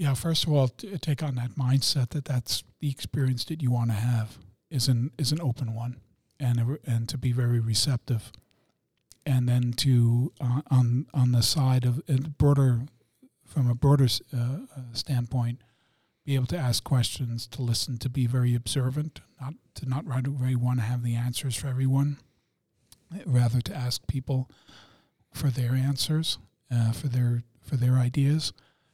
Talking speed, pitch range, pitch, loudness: 170 wpm, 120-140 Hz, 125 Hz, -27 LUFS